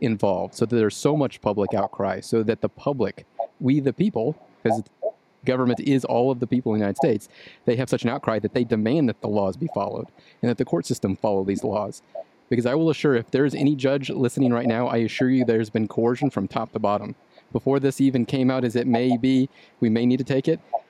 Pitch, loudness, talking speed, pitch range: 125 Hz, -23 LUFS, 240 wpm, 115-135 Hz